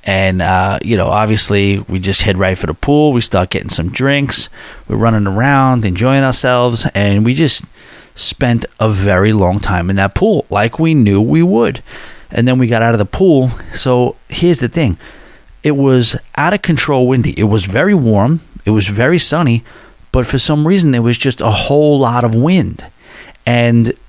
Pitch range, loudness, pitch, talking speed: 100-135 Hz, -12 LUFS, 120 Hz, 190 wpm